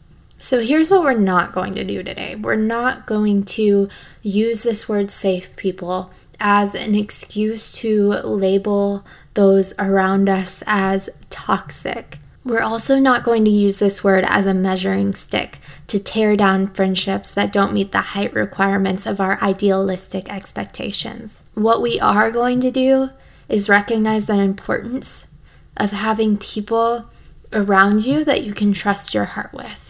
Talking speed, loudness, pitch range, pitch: 155 wpm, -18 LUFS, 195-225 Hz, 205 Hz